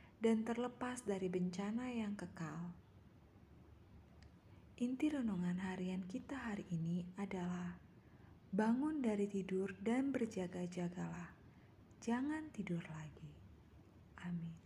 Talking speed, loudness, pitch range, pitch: 90 wpm, -42 LUFS, 175-235 Hz, 190 Hz